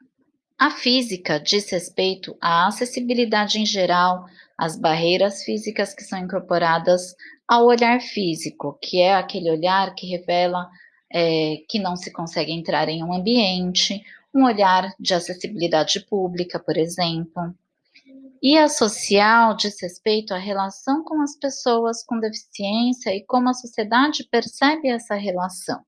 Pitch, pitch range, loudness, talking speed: 195 Hz, 180-235 Hz, -21 LUFS, 135 wpm